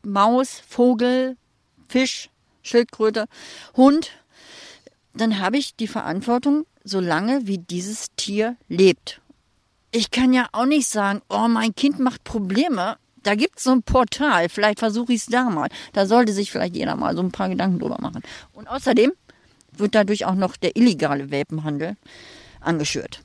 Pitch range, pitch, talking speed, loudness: 200-255 Hz, 225 Hz, 155 wpm, -21 LUFS